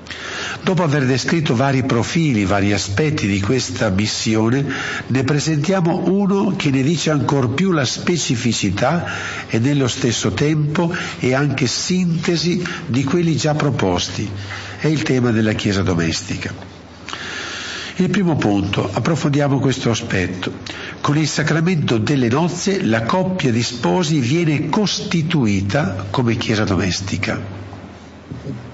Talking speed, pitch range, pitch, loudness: 120 wpm, 105-160 Hz, 135 Hz, -18 LUFS